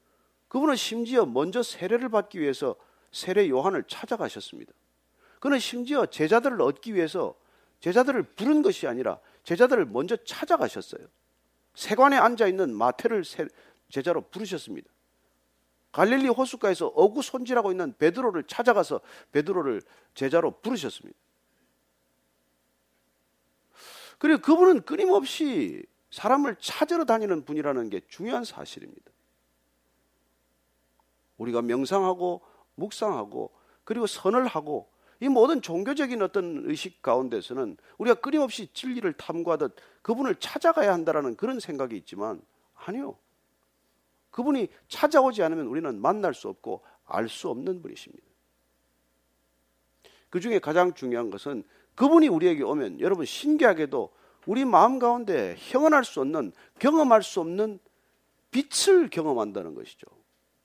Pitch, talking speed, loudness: 220 Hz, 300 characters per minute, -26 LUFS